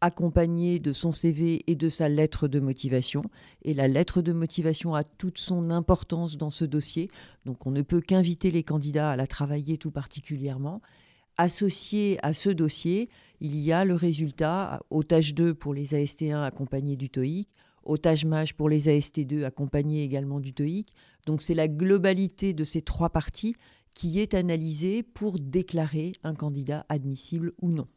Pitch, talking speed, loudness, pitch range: 160 Hz, 165 wpm, -28 LUFS, 145-175 Hz